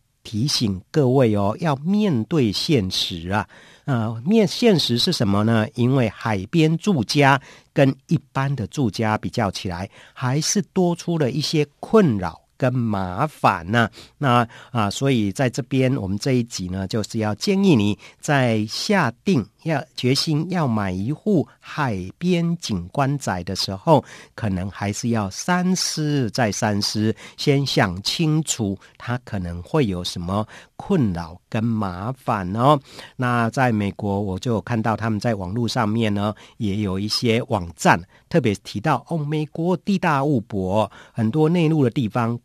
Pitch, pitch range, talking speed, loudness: 120 Hz, 105-150 Hz, 220 characters per minute, -21 LUFS